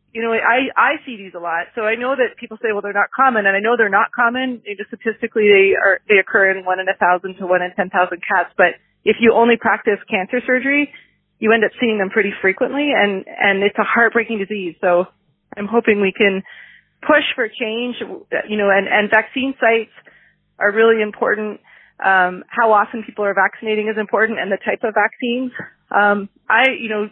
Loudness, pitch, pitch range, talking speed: -16 LUFS, 215 Hz, 200-235 Hz, 210 wpm